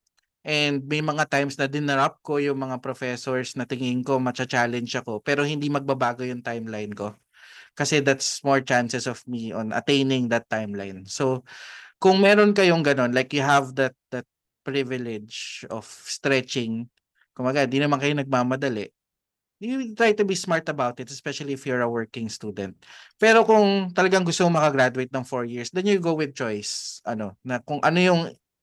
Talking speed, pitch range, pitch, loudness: 175 wpm, 120-150 Hz, 135 Hz, -23 LUFS